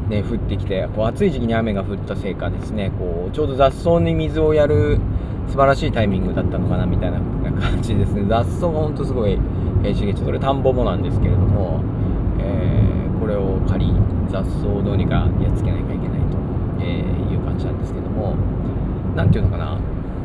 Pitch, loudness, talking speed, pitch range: 100 Hz, -20 LUFS, 395 characters per minute, 95-110 Hz